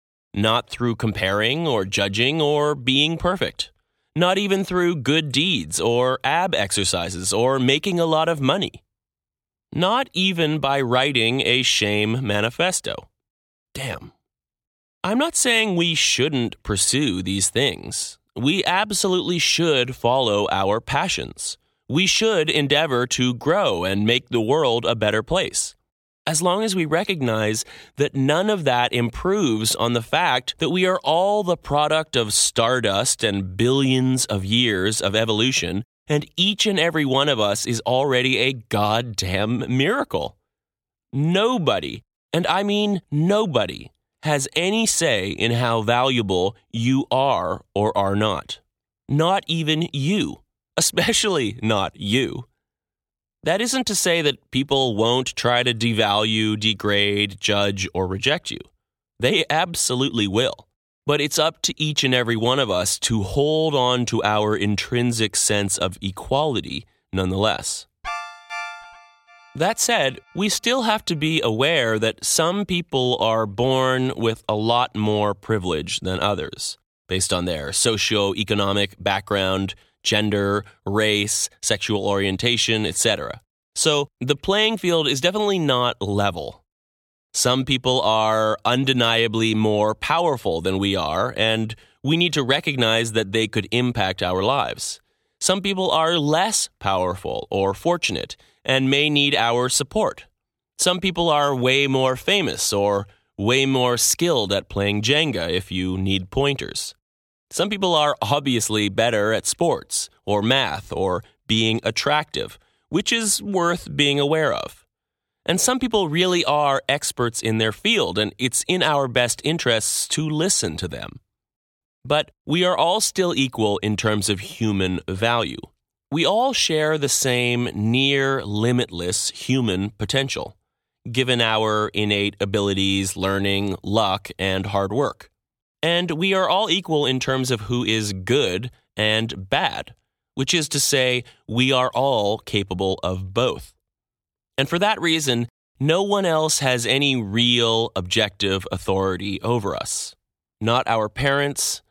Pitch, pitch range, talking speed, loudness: 125 Hz, 105-150 Hz, 135 wpm, -20 LUFS